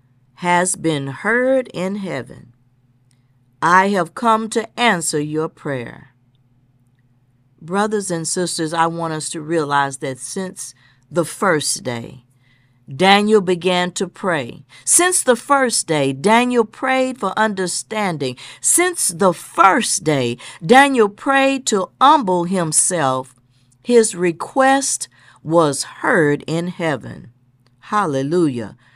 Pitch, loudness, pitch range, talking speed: 170 Hz, -17 LUFS, 130-205 Hz, 110 wpm